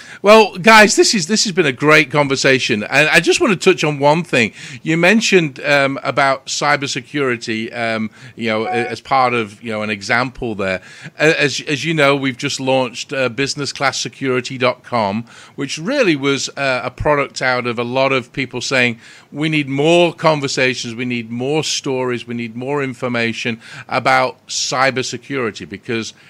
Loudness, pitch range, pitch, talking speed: -15 LUFS, 125-150 Hz, 135 Hz, 165 wpm